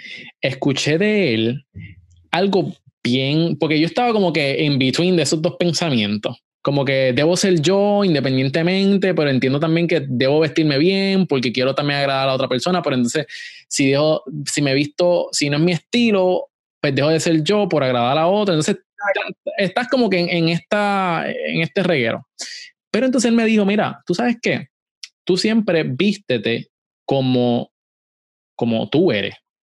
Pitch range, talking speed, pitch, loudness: 135-195 Hz, 170 wpm, 165 Hz, -18 LUFS